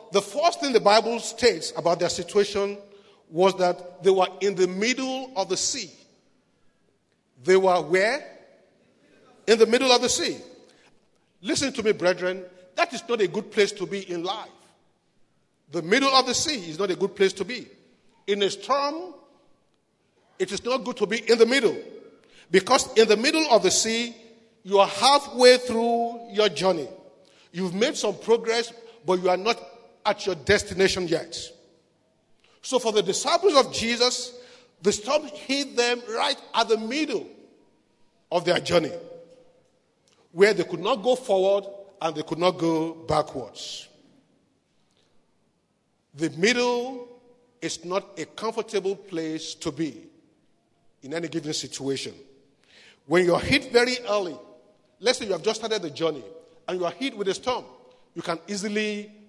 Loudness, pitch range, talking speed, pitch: -24 LUFS, 180-245 Hz, 160 wpm, 210 Hz